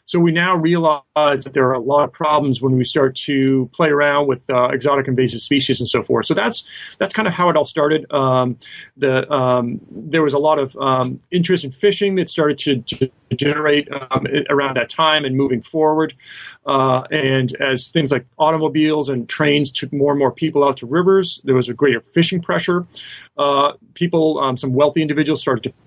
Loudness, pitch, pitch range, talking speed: -17 LUFS, 145 Hz, 130-155 Hz, 205 wpm